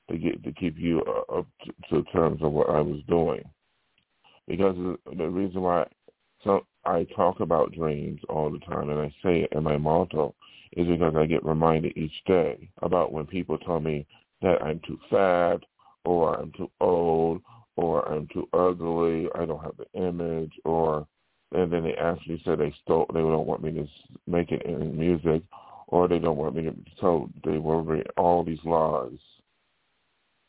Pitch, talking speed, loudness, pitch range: 80 Hz, 175 wpm, -27 LUFS, 80-85 Hz